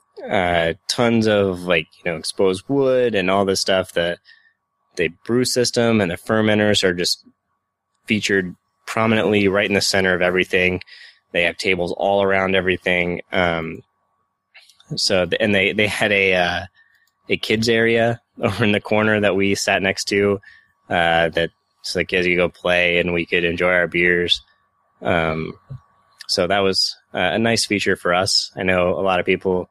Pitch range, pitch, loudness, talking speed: 90-105 Hz, 95 Hz, -18 LUFS, 175 wpm